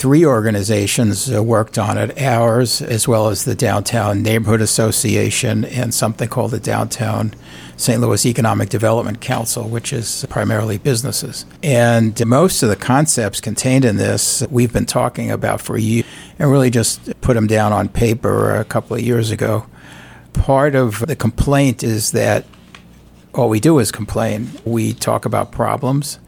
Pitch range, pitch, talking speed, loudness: 110-125 Hz, 115 Hz, 160 wpm, -16 LUFS